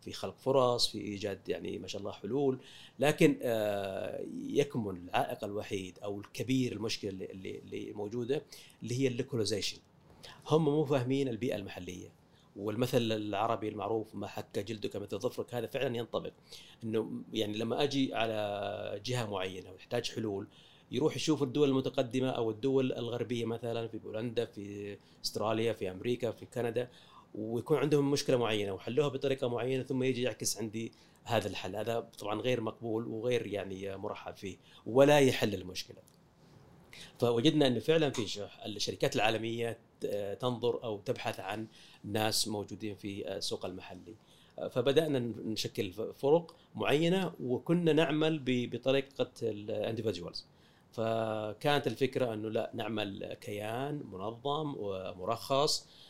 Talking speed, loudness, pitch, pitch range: 130 wpm, -34 LUFS, 115 Hz, 105-135 Hz